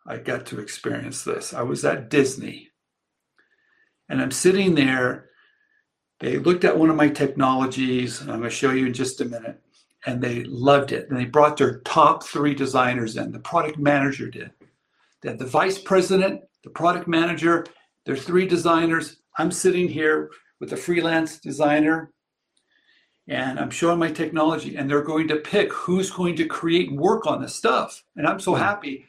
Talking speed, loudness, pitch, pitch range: 180 wpm, -22 LUFS, 155 Hz, 135-175 Hz